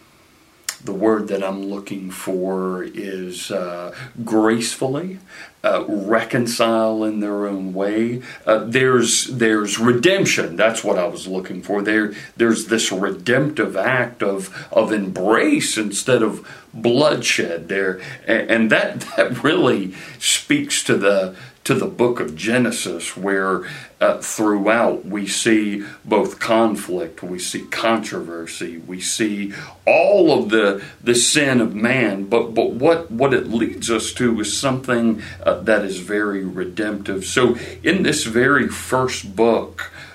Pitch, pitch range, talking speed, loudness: 110 Hz, 95-115 Hz, 135 wpm, -19 LUFS